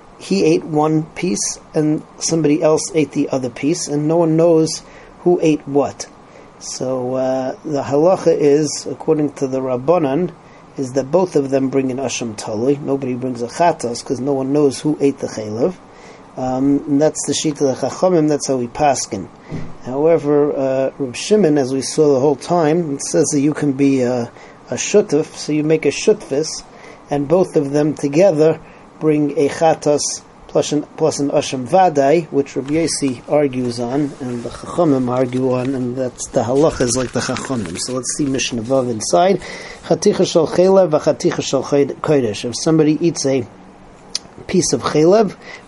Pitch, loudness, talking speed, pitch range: 145 Hz, -17 LUFS, 170 wpm, 130-155 Hz